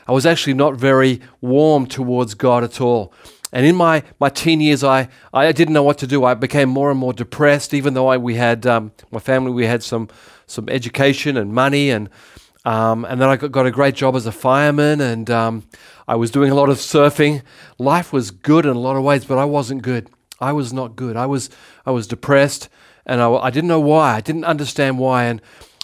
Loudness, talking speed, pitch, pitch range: -16 LUFS, 230 wpm, 130 Hz, 120-145 Hz